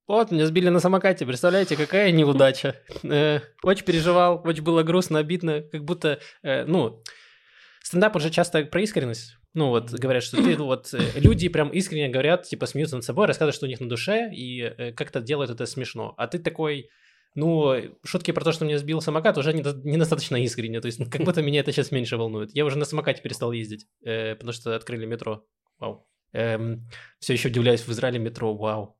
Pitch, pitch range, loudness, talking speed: 145 Hz, 120-165 Hz, -24 LUFS, 195 wpm